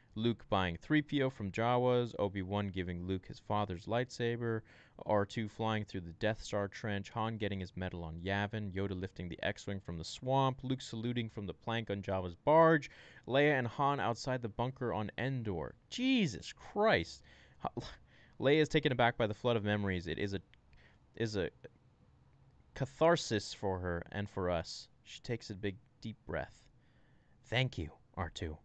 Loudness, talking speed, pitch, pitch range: -36 LUFS, 170 wpm, 110 Hz, 95-125 Hz